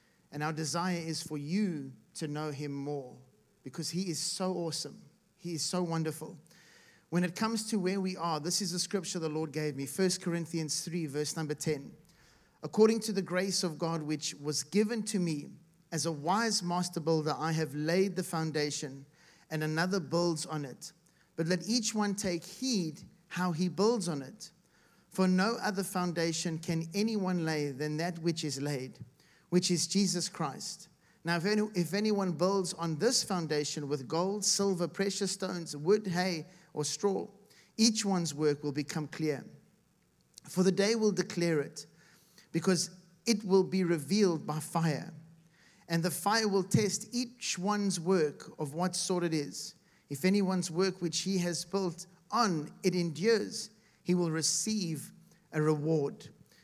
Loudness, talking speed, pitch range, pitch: -32 LUFS, 165 wpm, 155-190 Hz, 175 Hz